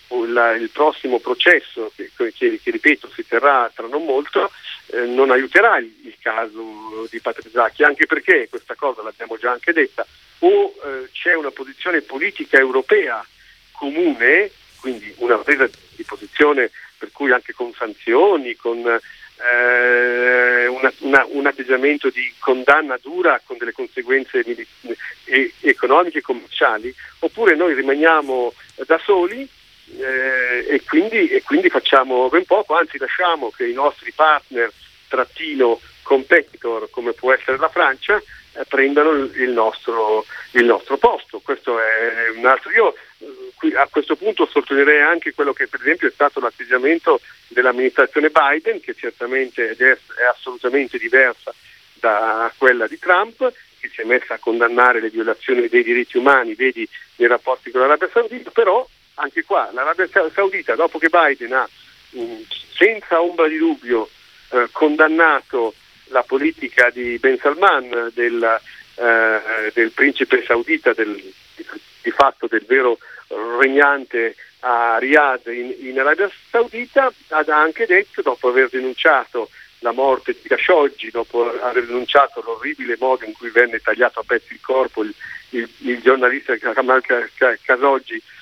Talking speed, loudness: 145 wpm, -17 LUFS